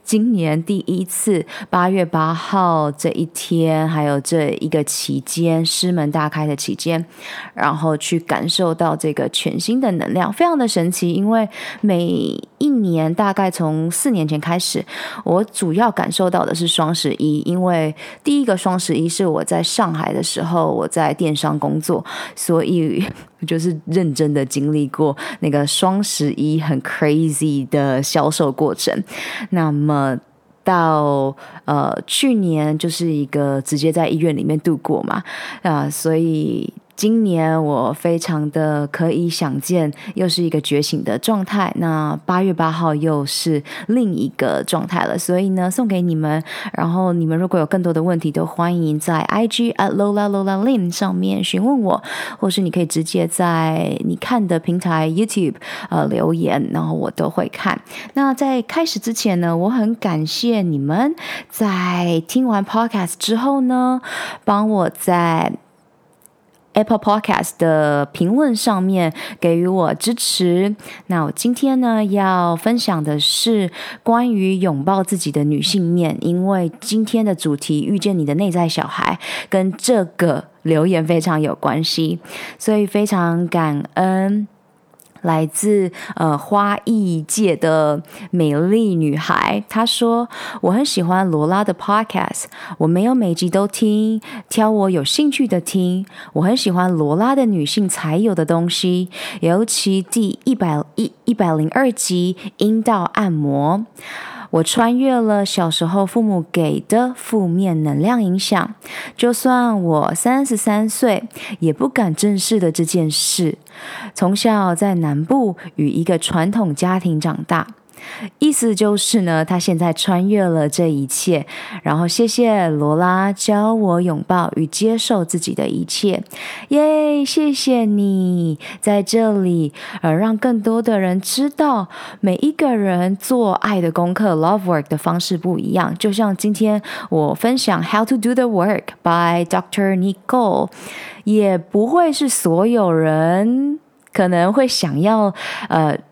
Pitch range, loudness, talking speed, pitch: 160-215 Hz, -17 LUFS, 240 characters per minute, 185 Hz